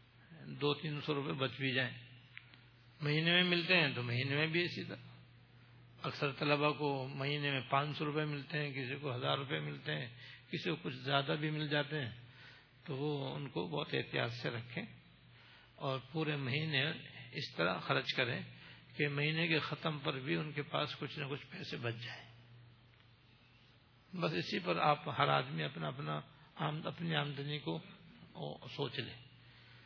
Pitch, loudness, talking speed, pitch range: 135 Hz, -37 LUFS, 170 wpm, 120-150 Hz